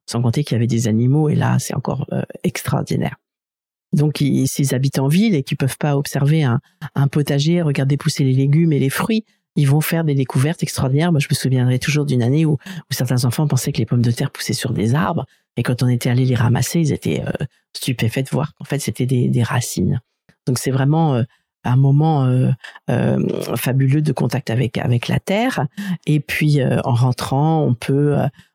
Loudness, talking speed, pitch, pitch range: -18 LUFS, 215 wpm, 140 Hz, 125-155 Hz